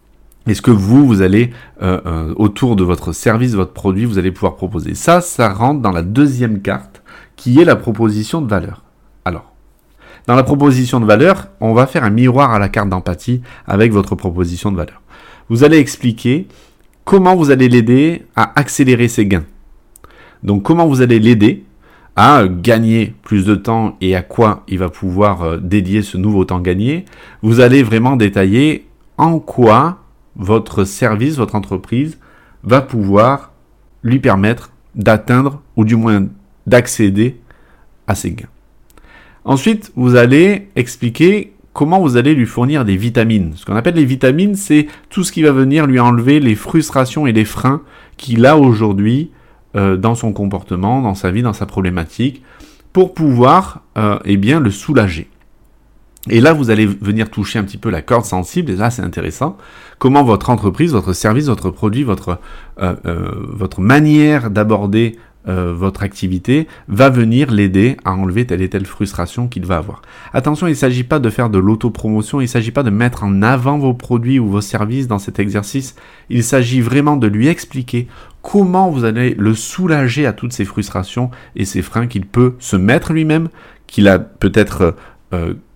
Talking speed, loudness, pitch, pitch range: 175 wpm, -13 LUFS, 115 Hz, 100-135 Hz